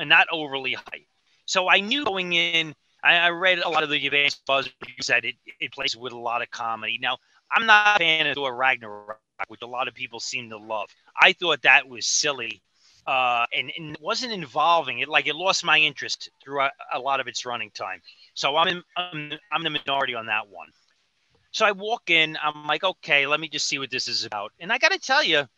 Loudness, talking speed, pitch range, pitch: -22 LUFS, 230 wpm, 125-170 Hz, 150 Hz